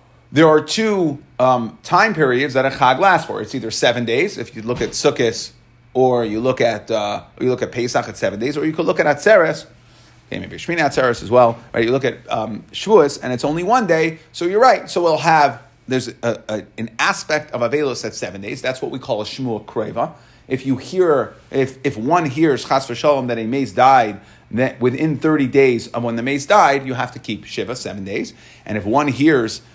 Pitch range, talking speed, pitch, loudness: 120-150 Hz, 225 wpm, 130 Hz, -18 LUFS